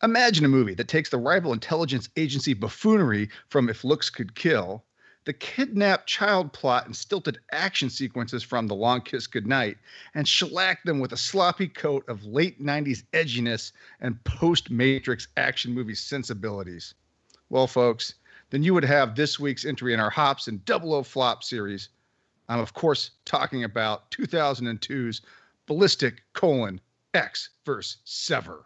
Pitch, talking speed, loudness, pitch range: 130 Hz, 155 wpm, -25 LUFS, 115-155 Hz